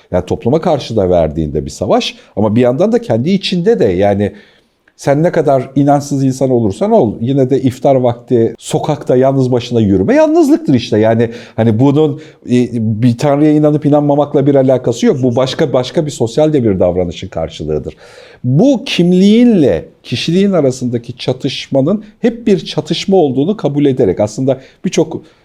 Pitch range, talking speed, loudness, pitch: 120-160 Hz, 155 wpm, -12 LUFS, 135 Hz